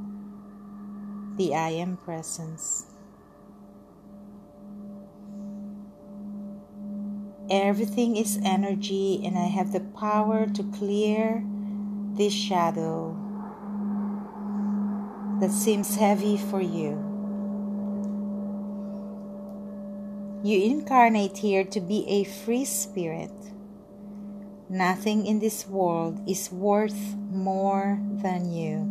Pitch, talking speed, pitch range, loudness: 205 Hz, 80 wpm, 195-205 Hz, -27 LUFS